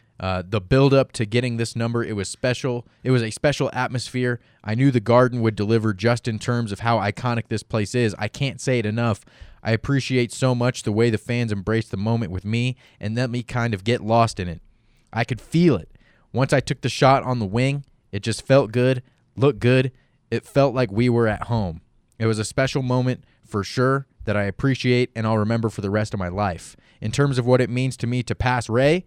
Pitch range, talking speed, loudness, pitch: 110-130 Hz, 230 wpm, -22 LUFS, 120 Hz